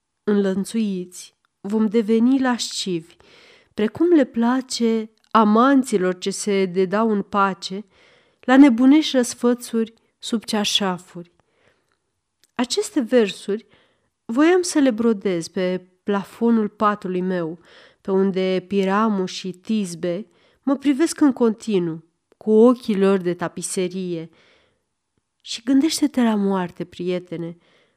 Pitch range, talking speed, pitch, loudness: 185-245 Hz, 100 wpm, 215 Hz, -20 LUFS